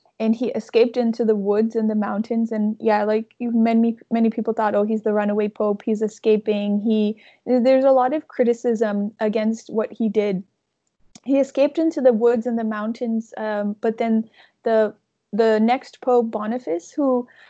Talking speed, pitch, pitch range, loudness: 170 wpm, 225 Hz, 215-240 Hz, -21 LUFS